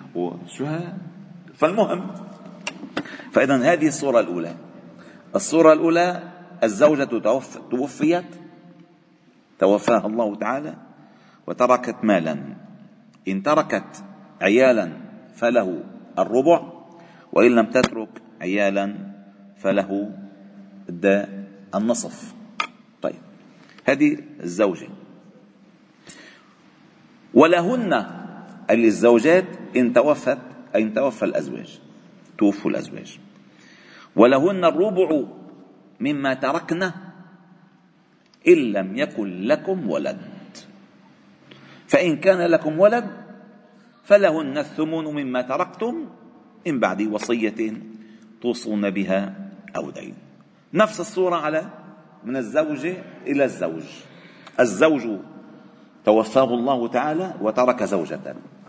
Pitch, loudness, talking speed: 170 Hz, -21 LUFS, 75 wpm